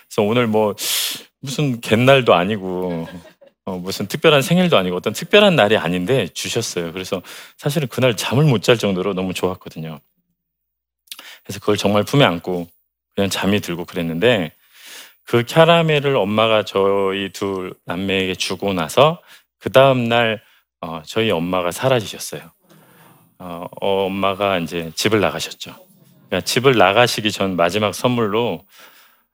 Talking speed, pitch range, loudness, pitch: 300 characters per minute, 90-120 Hz, -18 LUFS, 100 Hz